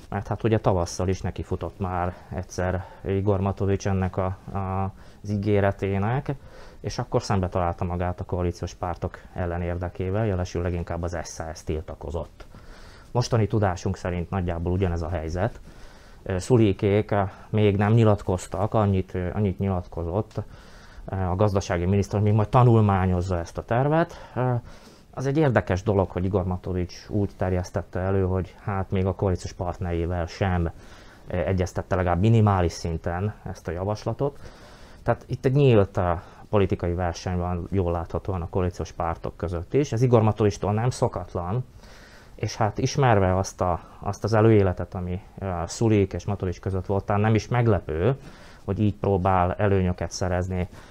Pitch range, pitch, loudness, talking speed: 90-105 Hz, 95 Hz, -25 LUFS, 140 wpm